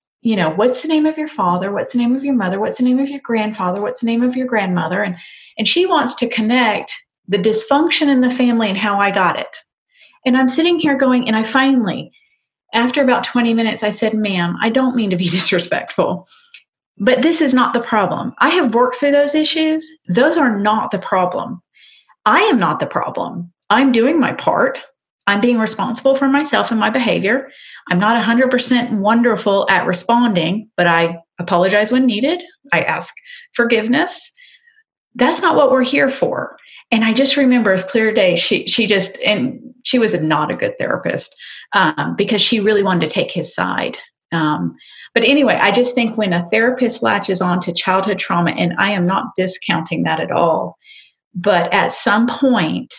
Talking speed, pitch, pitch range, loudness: 195 wpm, 235 Hz, 200-270 Hz, -16 LUFS